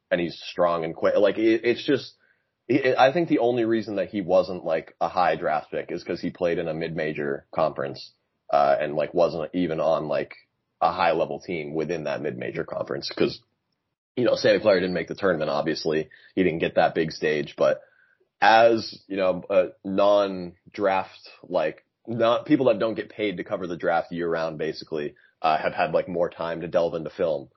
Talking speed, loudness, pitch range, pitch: 195 wpm, -24 LUFS, 85-115 Hz, 100 Hz